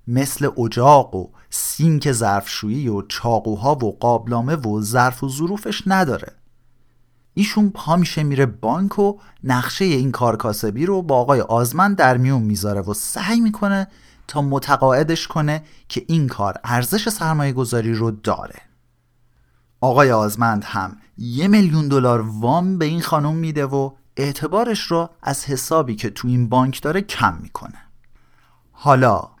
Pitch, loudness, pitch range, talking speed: 135 Hz, -19 LUFS, 120-160 Hz, 140 wpm